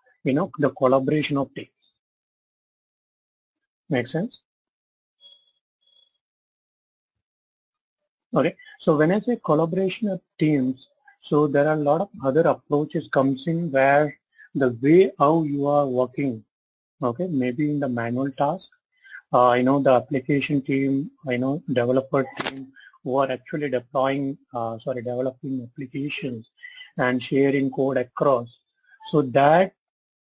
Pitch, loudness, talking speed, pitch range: 140 Hz, -23 LUFS, 125 wpm, 130-165 Hz